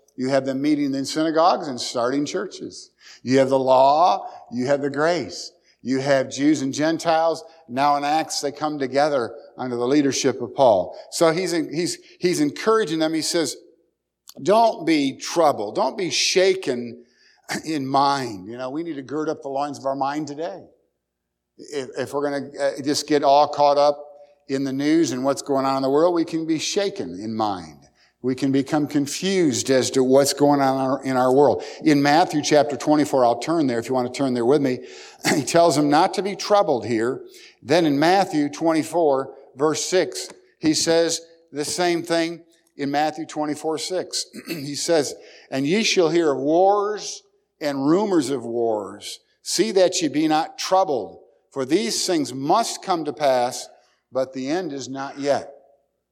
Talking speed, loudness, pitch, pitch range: 180 wpm, -21 LUFS, 145 Hz, 135-165 Hz